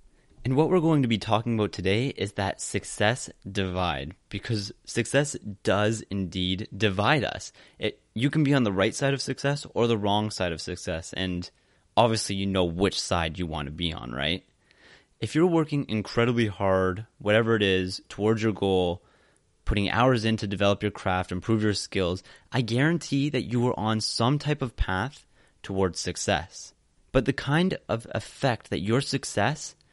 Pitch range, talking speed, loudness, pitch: 95-125 Hz, 175 wpm, -27 LUFS, 105 Hz